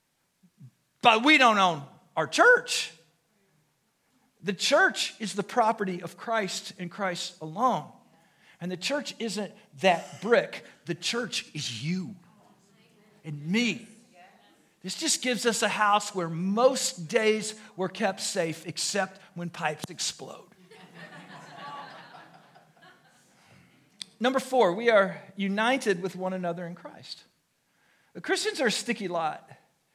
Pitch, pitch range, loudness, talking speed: 200 Hz, 175-230 Hz, -27 LUFS, 120 wpm